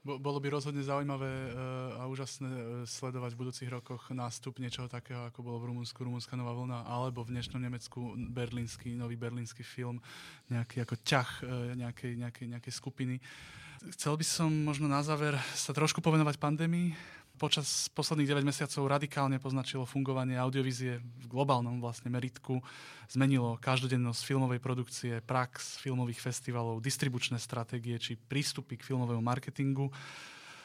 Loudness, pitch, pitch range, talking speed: -35 LUFS, 130 Hz, 120-140 Hz, 140 wpm